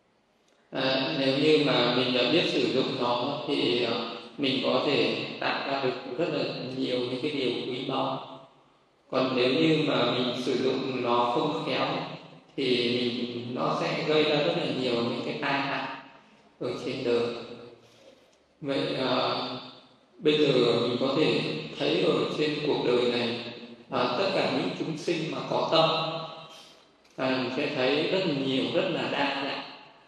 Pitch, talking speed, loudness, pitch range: 130 Hz, 165 wpm, -27 LUFS, 120-145 Hz